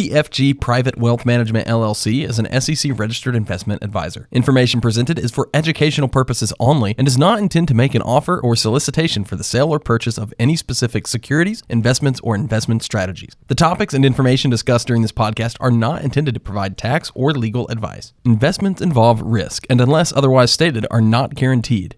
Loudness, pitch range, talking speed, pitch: -17 LUFS, 115-140 Hz, 185 wpm, 120 Hz